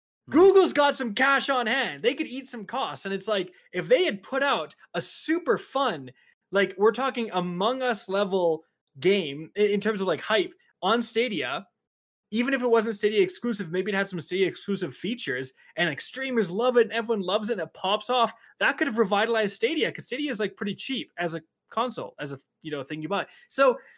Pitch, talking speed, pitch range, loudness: 225 Hz, 210 wpm, 190-255 Hz, -26 LUFS